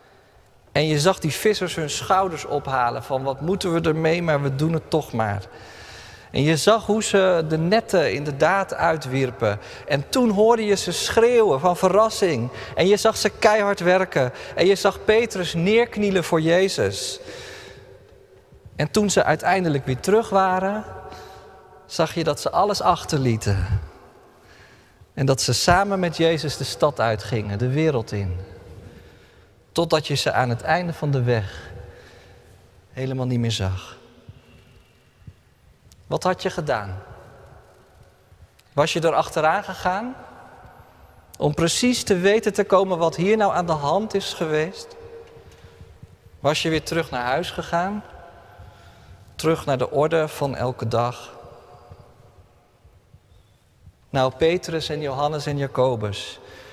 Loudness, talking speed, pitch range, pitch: -21 LUFS, 140 wpm, 120-190 Hz, 155 Hz